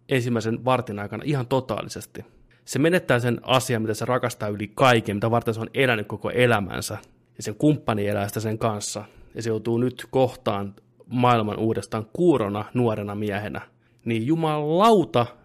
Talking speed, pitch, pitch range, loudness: 155 wpm, 115 Hz, 110-125 Hz, -23 LUFS